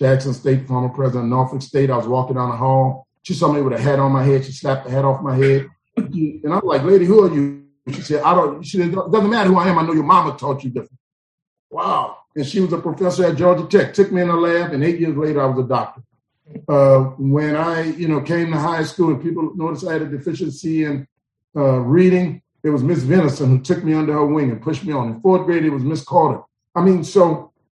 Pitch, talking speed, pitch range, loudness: 150 Hz, 260 wpm, 135-170 Hz, -17 LUFS